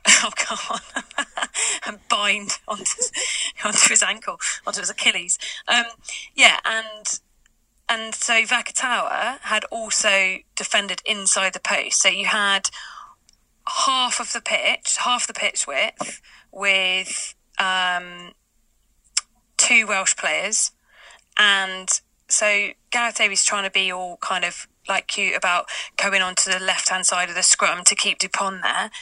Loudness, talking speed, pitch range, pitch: -20 LUFS, 135 wpm, 185-235 Hz, 205 Hz